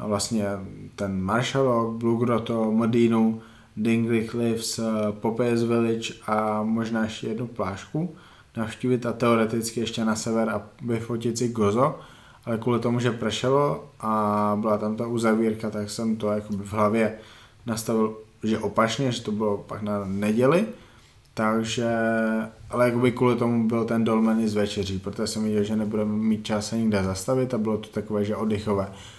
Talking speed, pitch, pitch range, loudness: 150 wpm, 110 Hz, 105-115 Hz, -25 LUFS